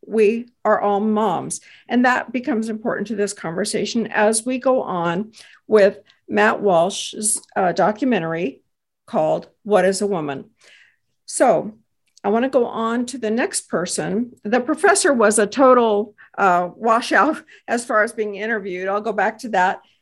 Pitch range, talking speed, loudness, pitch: 200-235 Hz, 155 wpm, -19 LUFS, 215 Hz